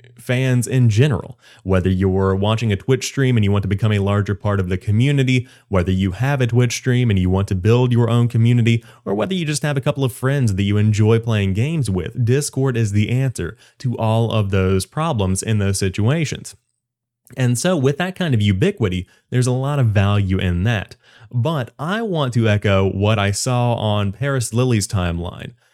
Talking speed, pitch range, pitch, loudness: 205 wpm, 100-130 Hz, 115 Hz, -18 LUFS